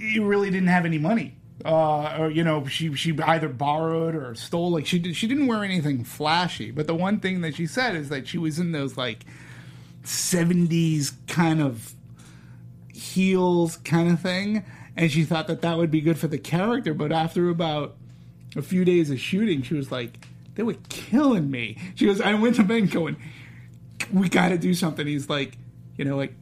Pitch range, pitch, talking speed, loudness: 135-180 Hz, 160 Hz, 200 wpm, -24 LUFS